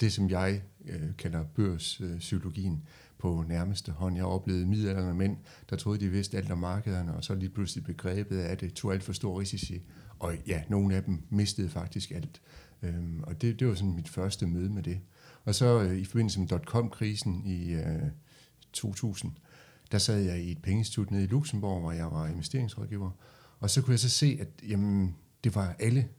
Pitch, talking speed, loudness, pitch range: 95 Hz, 195 wpm, -32 LUFS, 90-110 Hz